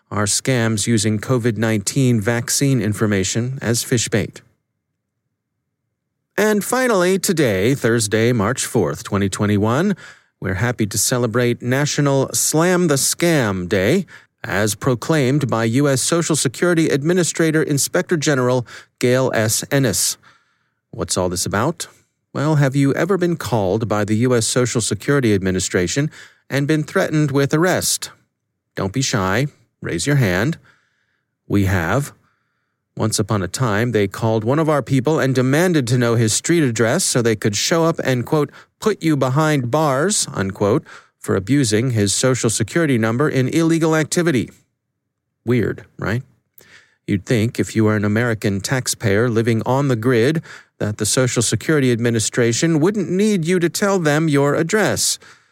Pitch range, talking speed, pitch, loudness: 110-155 Hz, 140 wpm, 130 Hz, -18 LUFS